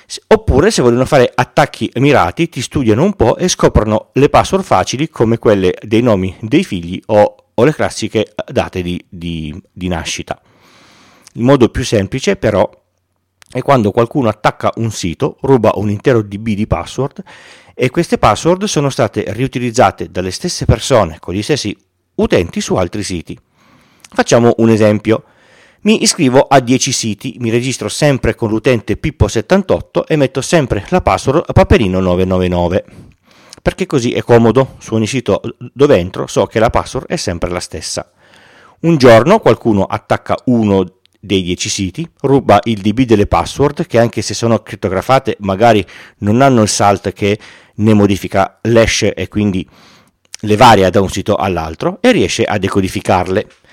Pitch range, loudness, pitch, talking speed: 95-130 Hz, -13 LUFS, 110 Hz, 155 wpm